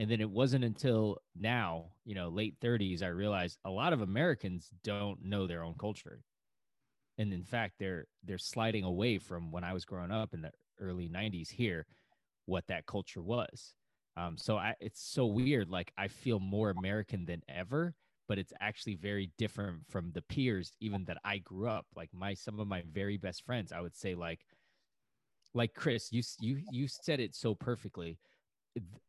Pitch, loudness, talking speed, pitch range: 100 Hz, -38 LUFS, 185 wpm, 90-115 Hz